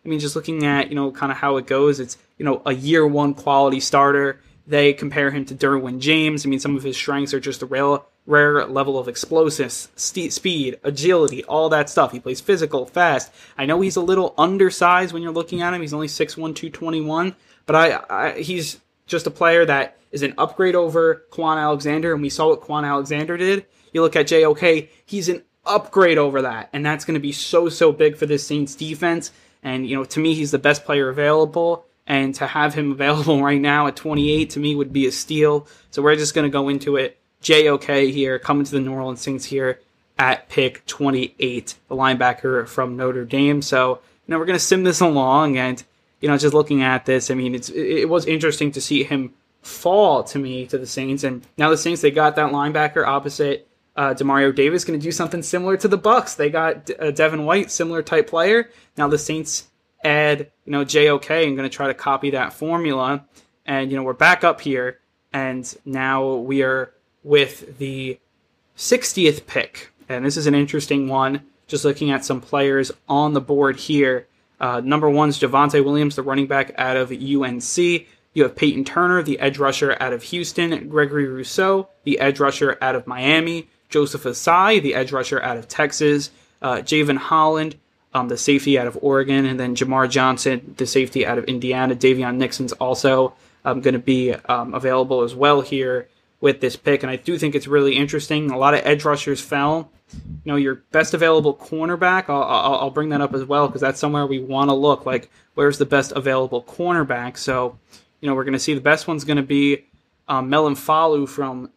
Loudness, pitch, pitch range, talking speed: -19 LUFS, 145 Hz, 135-155 Hz, 205 wpm